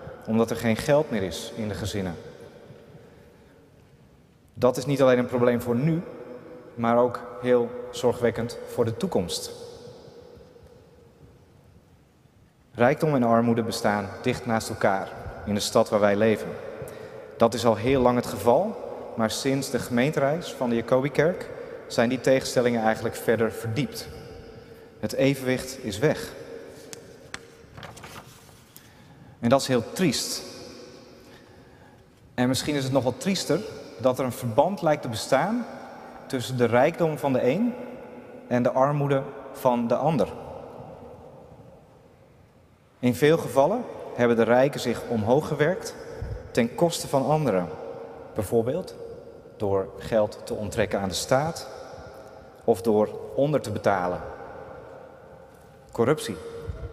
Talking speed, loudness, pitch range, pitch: 125 wpm, -25 LUFS, 115-165 Hz, 130 Hz